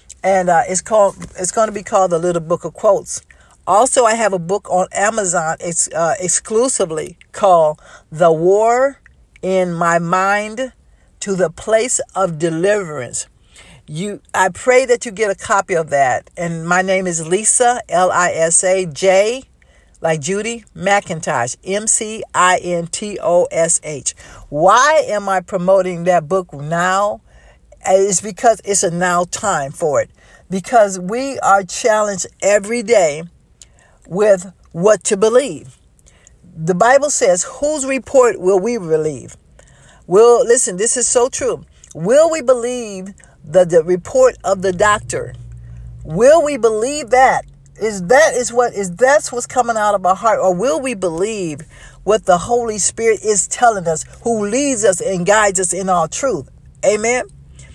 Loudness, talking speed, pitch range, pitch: -15 LUFS, 160 wpm, 175-230 Hz, 195 Hz